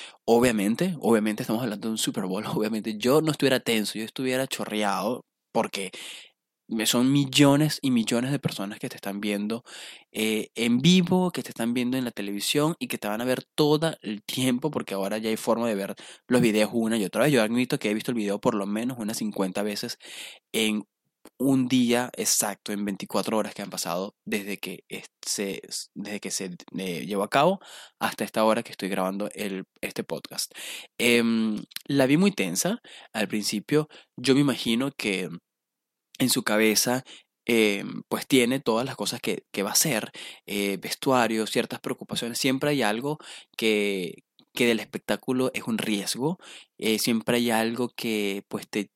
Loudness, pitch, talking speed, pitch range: -26 LUFS, 115 Hz, 180 wpm, 105-130 Hz